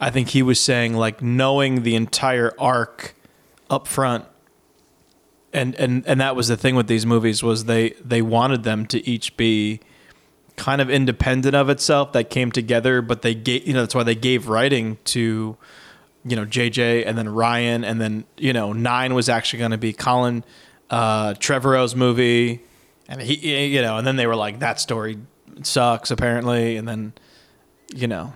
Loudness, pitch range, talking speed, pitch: -20 LUFS, 115-130 Hz, 180 wpm, 120 Hz